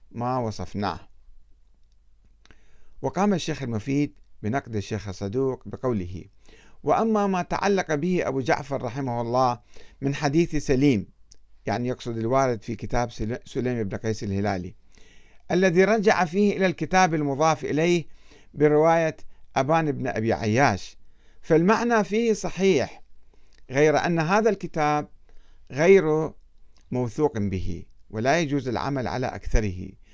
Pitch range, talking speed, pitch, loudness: 110-165 Hz, 110 wpm, 135 Hz, -24 LUFS